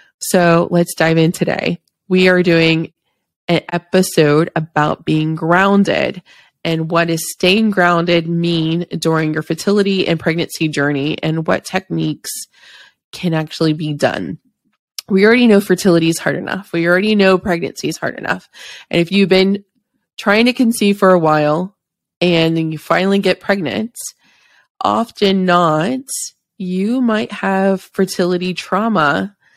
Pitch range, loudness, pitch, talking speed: 165-195 Hz, -15 LUFS, 175 Hz, 140 wpm